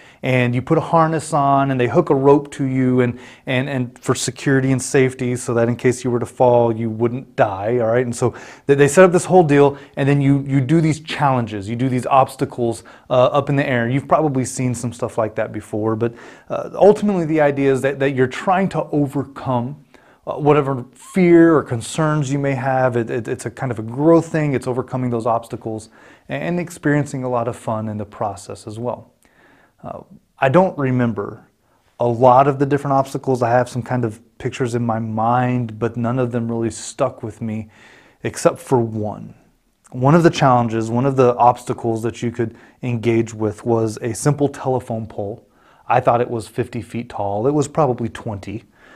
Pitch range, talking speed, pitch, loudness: 115-140 Hz, 205 wpm, 125 Hz, -18 LUFS